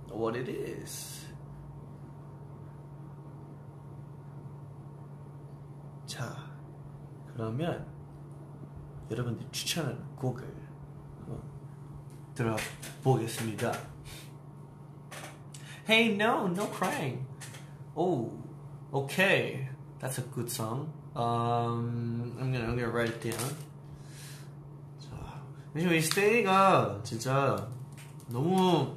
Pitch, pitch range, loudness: 145 Hz, 135-150 Hz, -31 LUFS